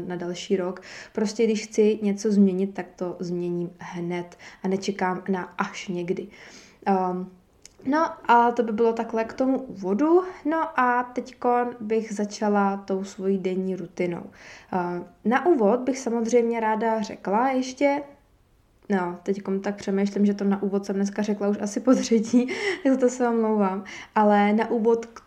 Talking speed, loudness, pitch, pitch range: 155 wpm, -24 LUFS, 210 Hz, 190-235 Hz